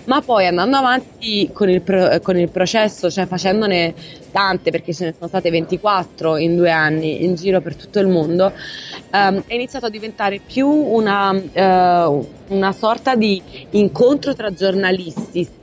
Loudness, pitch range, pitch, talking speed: -17 LUFS, 175-210 Hz, 190 Hz, 160 wpm